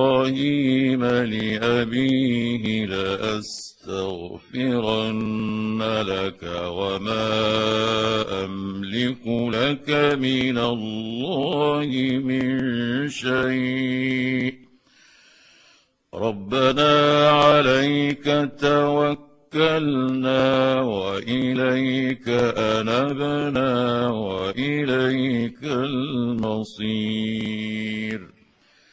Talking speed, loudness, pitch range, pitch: 35 wpm, -22 LUFS, 110-130 Hz, 125 Hz